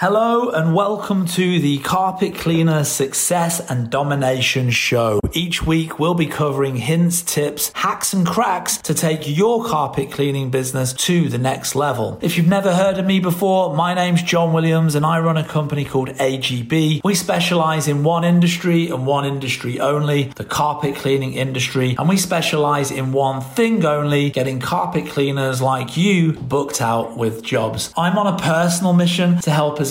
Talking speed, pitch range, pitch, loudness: 175 wpm, 135-175 Hz, 155 Hz, -18 LUFS